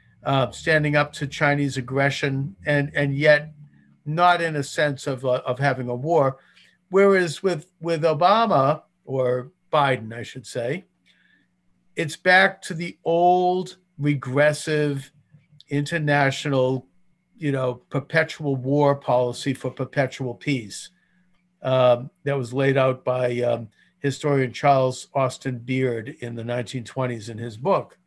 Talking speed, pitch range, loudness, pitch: 130 wpm, 130-155 Hz, -22 LUFS, 140 Hz